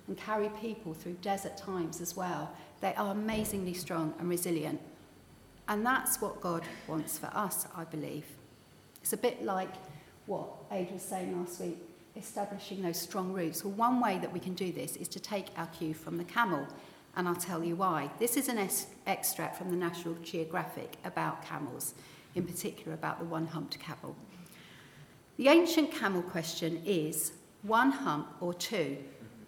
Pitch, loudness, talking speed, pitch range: 180 Hz, -34 LUFS, 175 wpm, 165-205 Hz